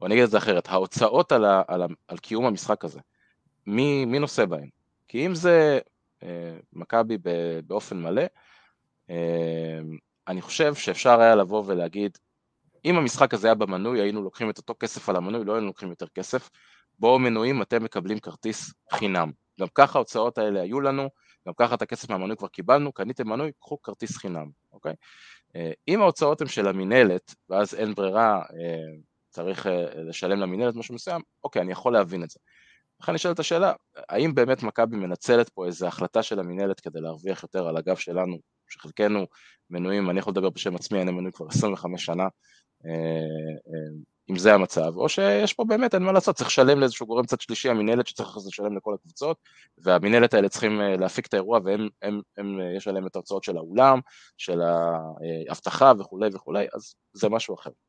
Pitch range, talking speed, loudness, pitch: 90-120 Hz, 175 wpm, -24 LUFS, 100 Hz